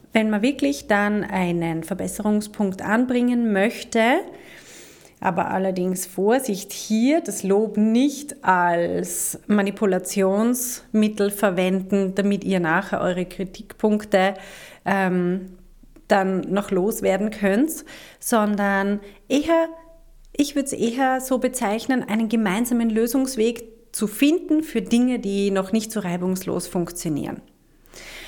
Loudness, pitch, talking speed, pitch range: -22 LUFS, 210 Hz, 105 wpm, 195-245 Hz